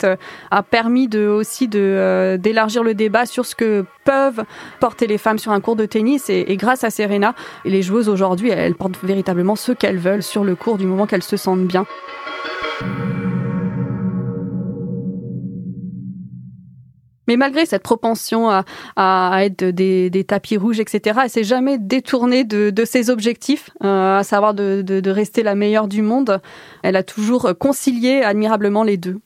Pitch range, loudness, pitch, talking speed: 190-235 Hz, -17 LUFS, 210 Hz, 170 wpm